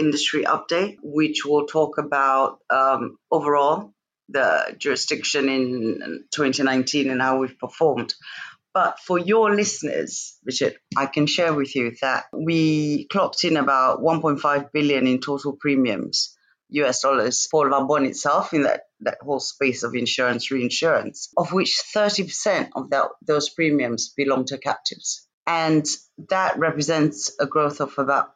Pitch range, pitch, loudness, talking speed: 135-155 Hz, 145 Hz, -22 LUFS, 140 wpm